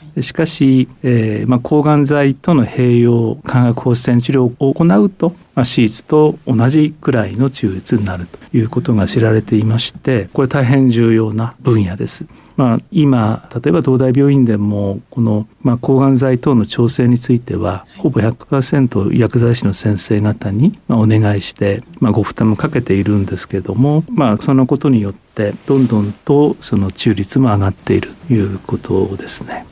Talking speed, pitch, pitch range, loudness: 325 characters per minute, 120 Hz, 110-135 Hz, -14 LUFS